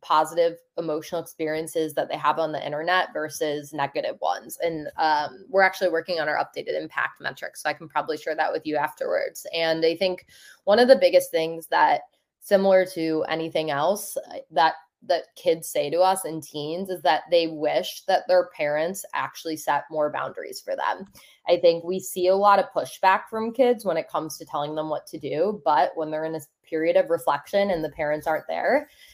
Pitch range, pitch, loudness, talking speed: 155-190 Hz, 165 Hz, -24 LUFS, 200 wpm